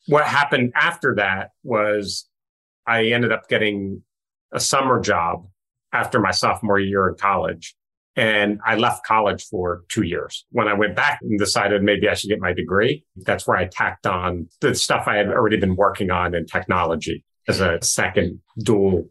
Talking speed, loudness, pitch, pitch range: 175 wpm, -20 LUFS, 100 Hz, 90-110 Hz